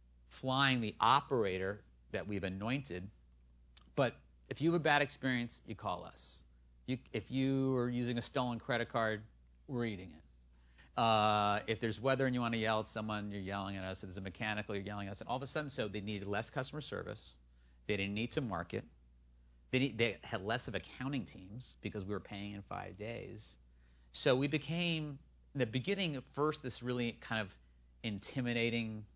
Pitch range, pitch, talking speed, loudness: 85-125 Hz, 105 Hz, 195 wpm, -37 LUFS